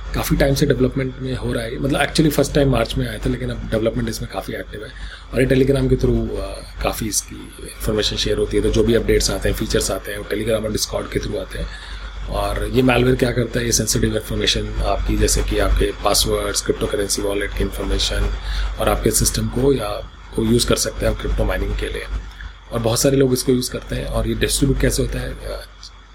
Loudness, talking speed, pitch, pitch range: -19 LUFS, 225 wpm, 115 Hz, 105-130 Hz